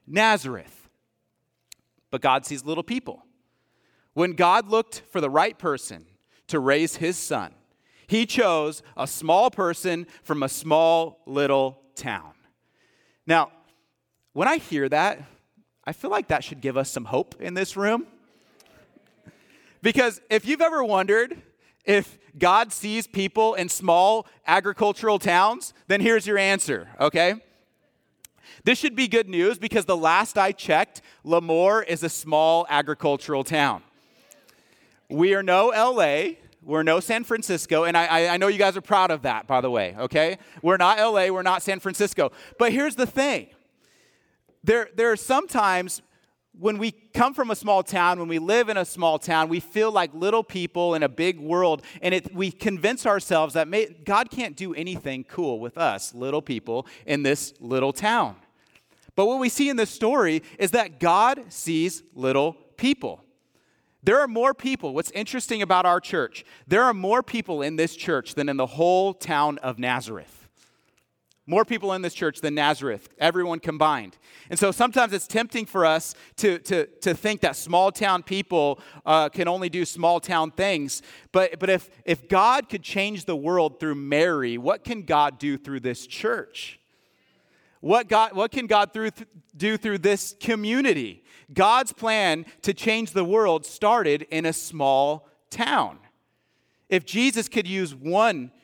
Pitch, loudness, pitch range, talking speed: 180 Hz, -23 LUFS, 155-215 Hz, 165 wpm